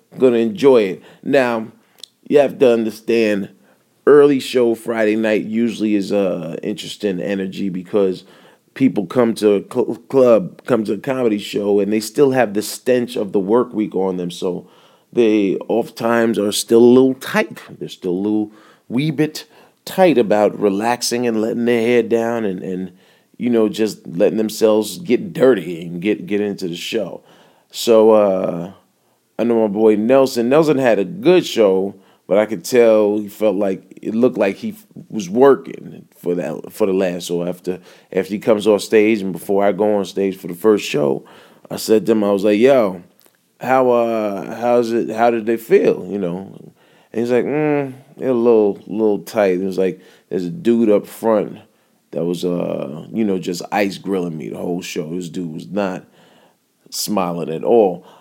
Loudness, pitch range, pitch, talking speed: -17 LUFS, 100-120 Hz, 110 Hz, 190 wpm